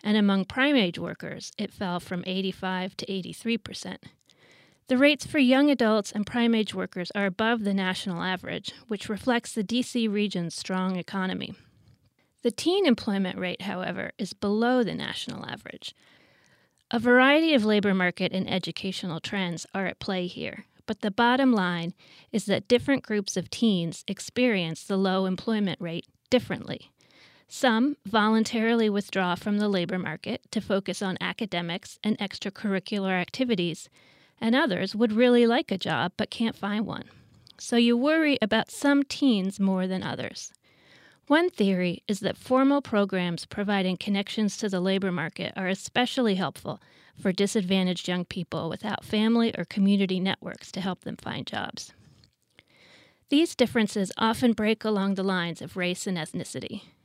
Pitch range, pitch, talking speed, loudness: 185-230 Hz, 200 Hz, 150 wpm, -26 LUFS